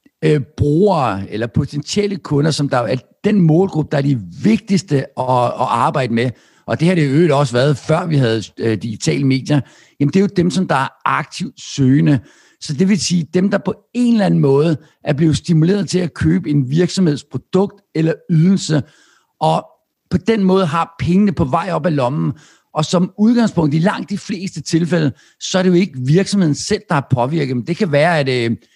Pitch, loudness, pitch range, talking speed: 160 Hz, -16 LUFS, 140-185 Hz, 195 wpm